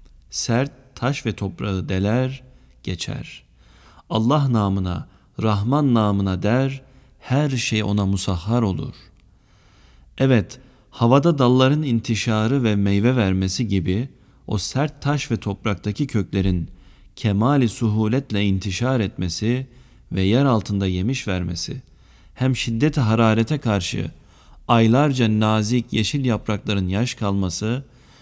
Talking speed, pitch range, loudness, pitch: 105 wpm, 100-125 Hz, -21 LUFS, 110 Hz